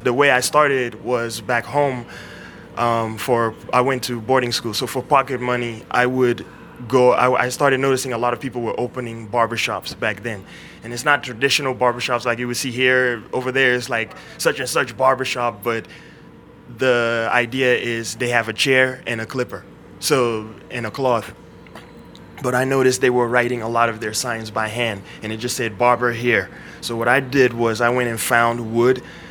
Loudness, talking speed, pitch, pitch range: -19 LUFS, 195 wpm, 120 Hz, 115-130 Hz